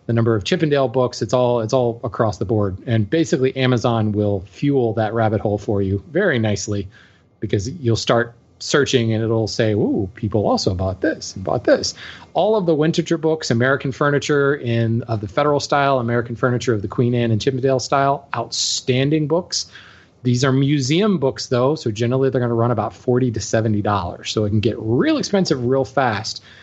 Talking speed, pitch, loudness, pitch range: 190 wpm, 120 Hz, -19 LUFS, 110-135 Hz